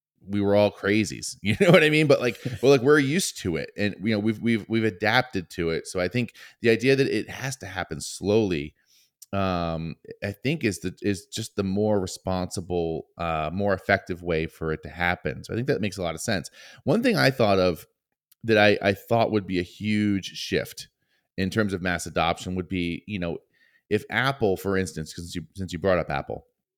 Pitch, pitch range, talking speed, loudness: 100 Hz, 90-110 Hz, 220 wpm, -25 LUFS